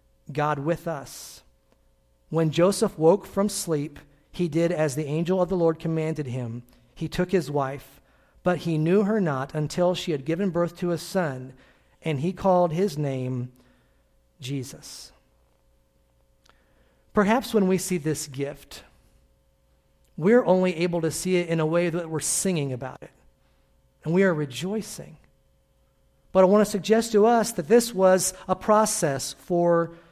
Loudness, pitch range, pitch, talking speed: -24 LUFS, 130-185 Hz, 165 Hz, 155 wpm